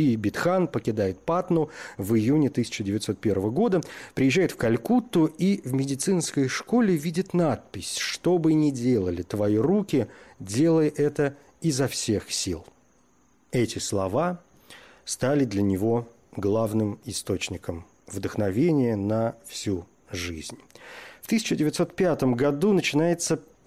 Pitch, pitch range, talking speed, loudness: 135 Hz, 105-165 Hz, 110 wpm, -25 LUFS